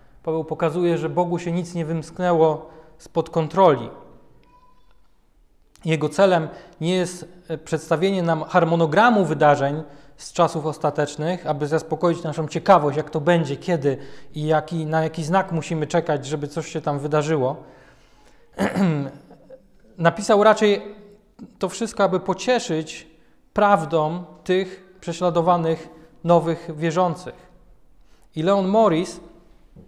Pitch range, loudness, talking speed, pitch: 155-185 Hz, -21 LUFS, 110 wpm, 165 Hz